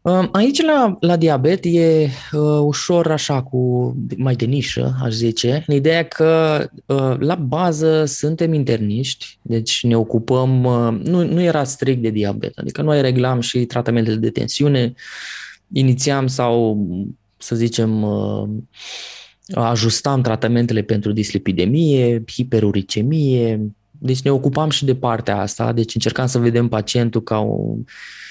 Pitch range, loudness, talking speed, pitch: 115-150 Hz, -18 LUFS, 135 wpm, 125 Hz